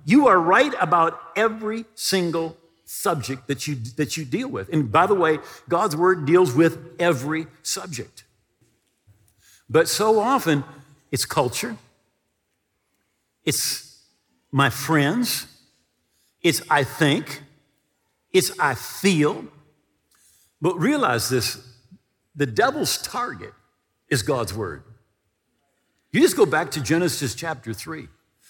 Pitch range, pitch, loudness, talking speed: 130-175 Hz, 155 Hz, -22 LUFS, 115 wpm